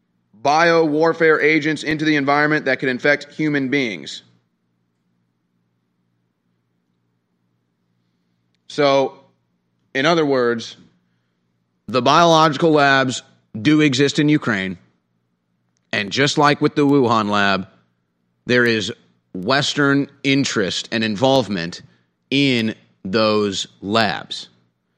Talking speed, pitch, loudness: 90 wpm, 105 Hz, -17 LUFS